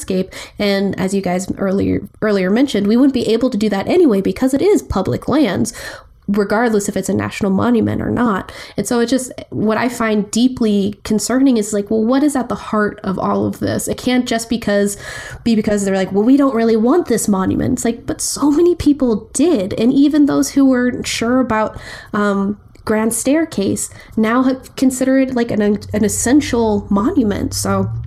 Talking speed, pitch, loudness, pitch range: 200 wpm, 225 Hz, -16 LUFS, 205-260 Hz